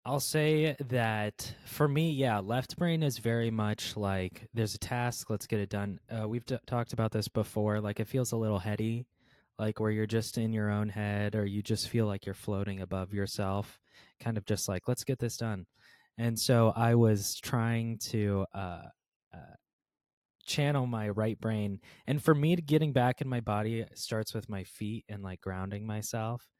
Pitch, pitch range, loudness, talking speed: 110 Hz, 105-120 Hz, -32 LUFS, 195 wpm